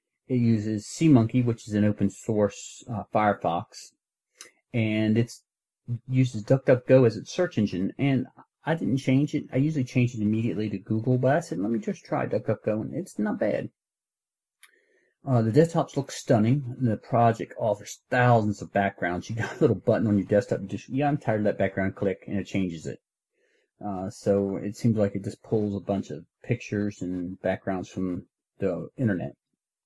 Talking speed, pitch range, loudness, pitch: 180 wpm, 100-125 Hz, -26 LUFS, 110 Hz